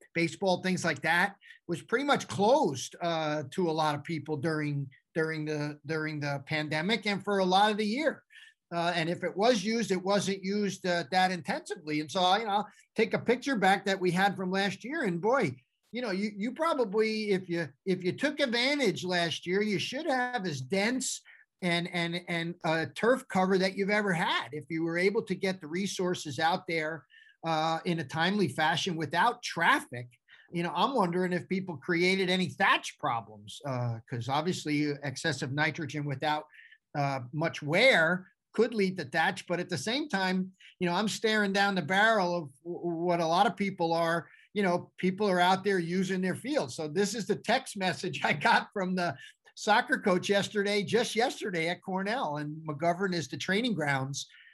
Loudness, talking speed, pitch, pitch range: -30 LUFS, 195 wpm, 185 Hz, 160-205 Hz